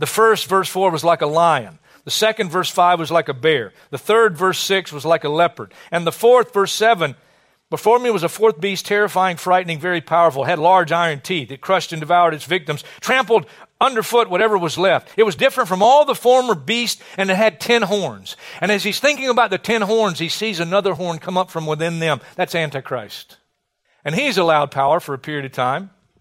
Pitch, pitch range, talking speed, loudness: 185 Hz, 165-215 Hz, 220 wpm, -17 LUFS